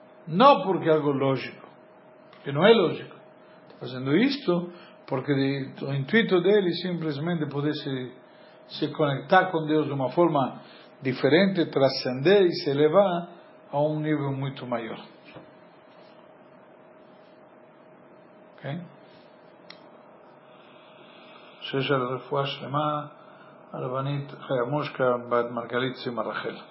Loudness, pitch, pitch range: -25 LUFS, 145 Hz, 135-165 Hz